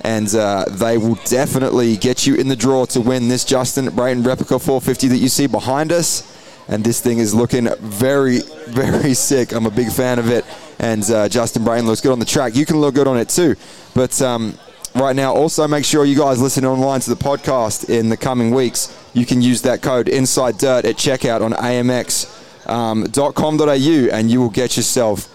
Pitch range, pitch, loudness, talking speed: 115-135 Hz, 125 Hz, -16 LUFS, 205 wpm